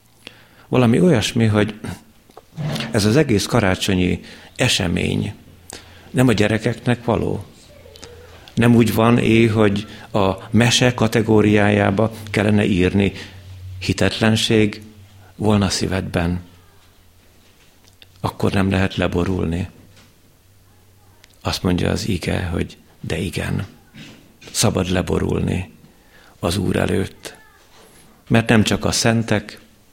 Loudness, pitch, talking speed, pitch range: -18 LUFS, 100 Hz, 90 wpm, 90-110 Hz